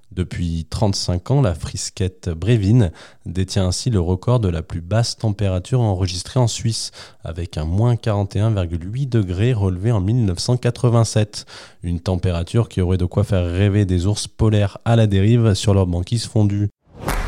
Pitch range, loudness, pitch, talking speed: 90-115 Hz, -19 LUFS, 105 Hz, 155 wpm